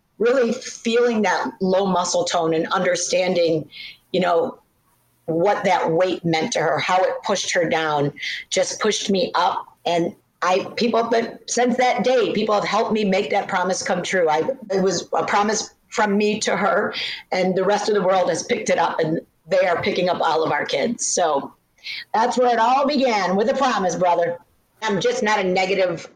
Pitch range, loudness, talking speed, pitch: 180-230 Hz, -20 LUFS, 195 wpm, 195 Hz